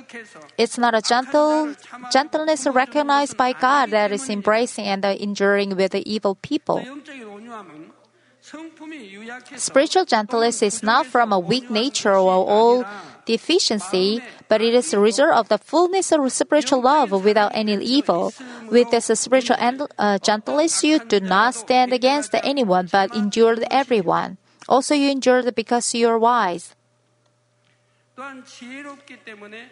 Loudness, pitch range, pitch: -19 LUFS, 215-275 Hz, 240 Hz